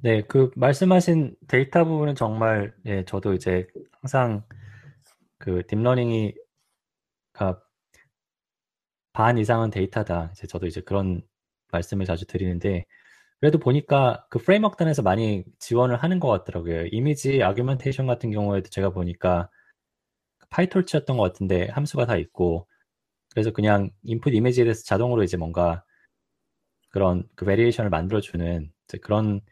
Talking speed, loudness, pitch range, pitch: 315 characters per minute, -24 LUFS, 95-125 Hz, 105 Hz